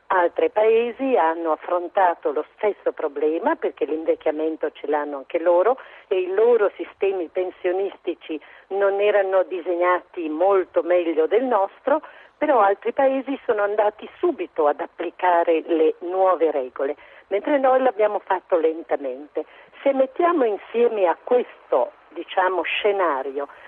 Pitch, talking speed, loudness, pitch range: 185 Hz, 120 wpm, -22 LUFS, 165-260 Hz